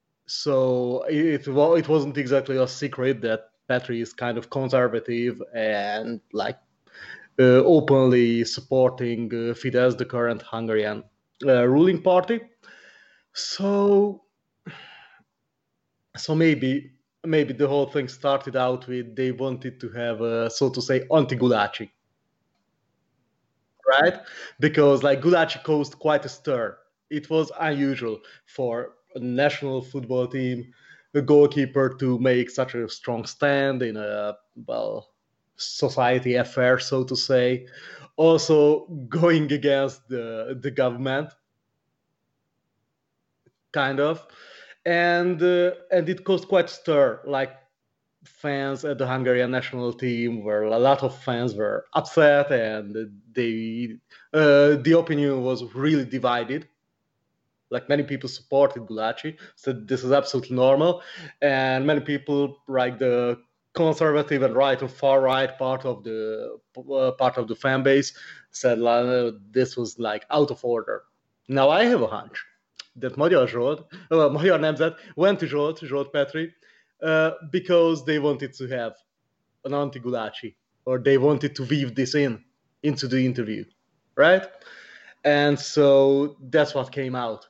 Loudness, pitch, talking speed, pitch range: -23 LUFS, 135 Hz, 130 wpm, 125-145 Hz